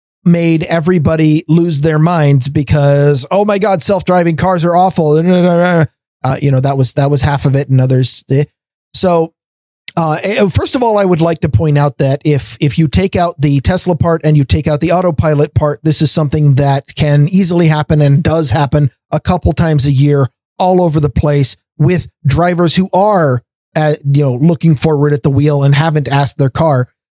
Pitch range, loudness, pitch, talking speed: 140-170 Hz, -11 LUFS, 155 Hz, 195 wpm